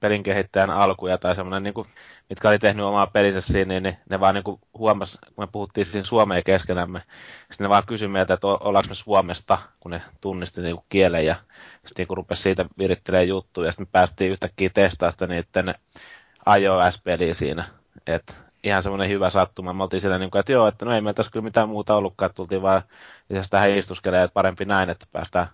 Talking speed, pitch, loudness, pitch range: 205 wpm, 95 Hz, -22 LUFS, 90-100 Hz